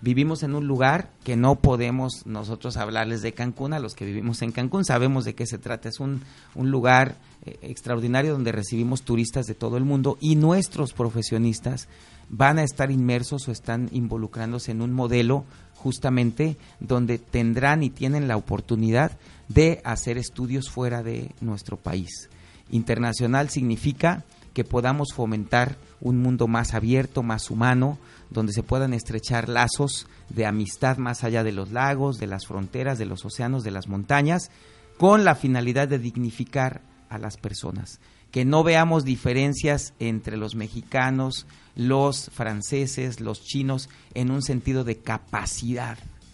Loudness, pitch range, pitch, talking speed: -24 LUFS, 115-135 Hz, 125 Hz, 155 wpm